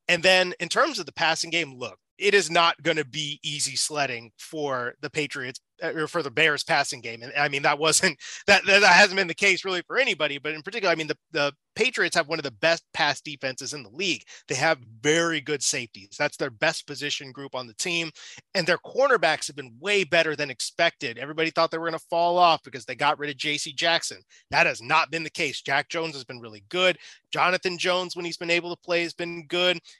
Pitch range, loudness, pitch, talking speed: 145-170 Hz, -24 LUFS, 160 Hz, 235 wpm